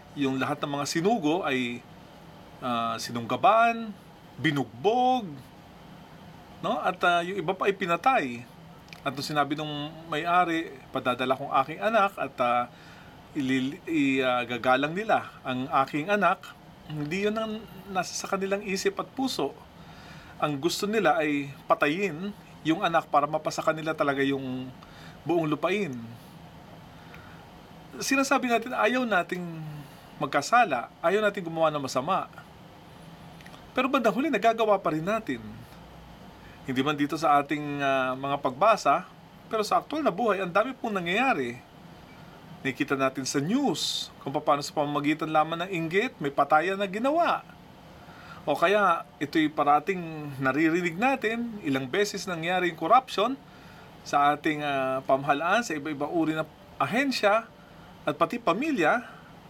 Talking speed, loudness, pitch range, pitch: 130 wpm, -27 LUFS, 145-200 Hz, 165 Hz